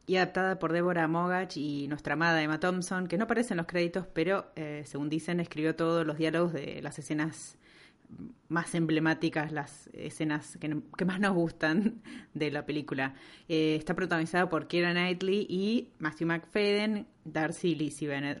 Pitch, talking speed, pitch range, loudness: 165 Hz, 165 wpm, 155-180 Hz, -31 LUFS